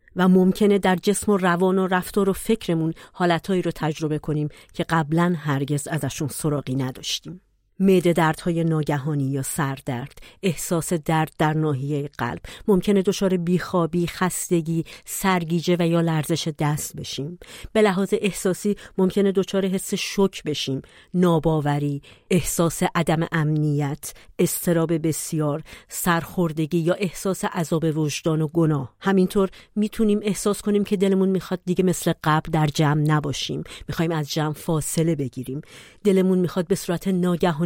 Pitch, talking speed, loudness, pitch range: 170 Hz, 135 wpm, -23 LUFS, 155-185 Hz